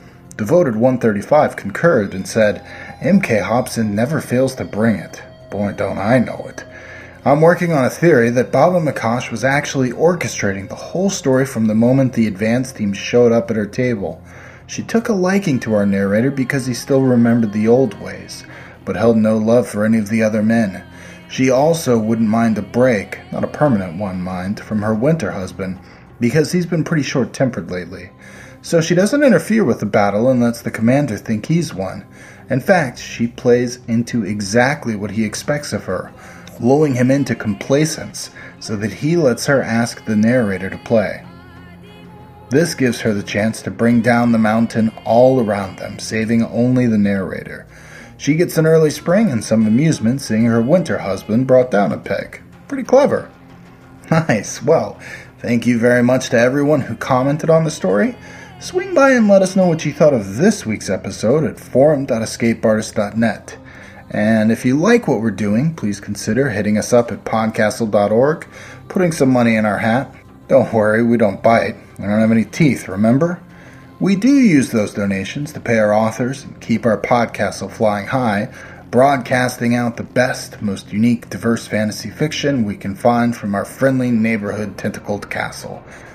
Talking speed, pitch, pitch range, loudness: 175 wpm, 115 Hz, 105-135 Hz, -16 LUFS